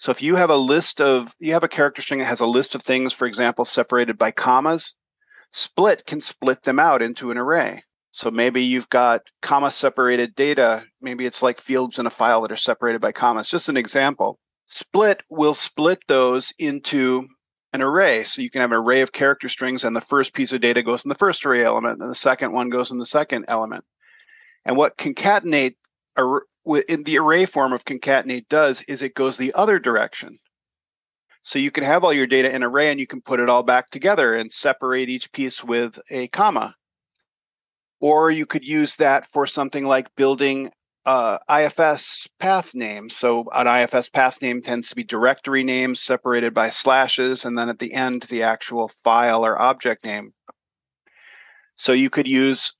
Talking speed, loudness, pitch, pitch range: 195 wpm, -19 LUFS, 130 Hz, 125-145 Hz